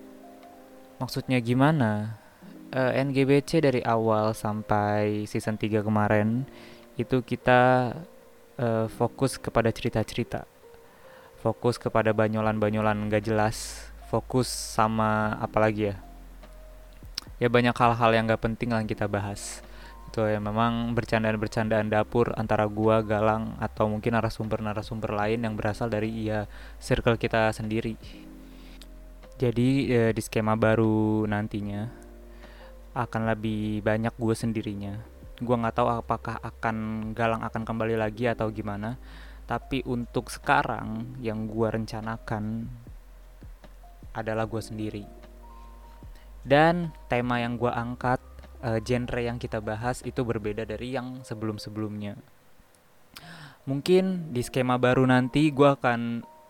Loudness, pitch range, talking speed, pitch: -27 LUFS, 110-120 Hz, 115 wpm, 115 Hz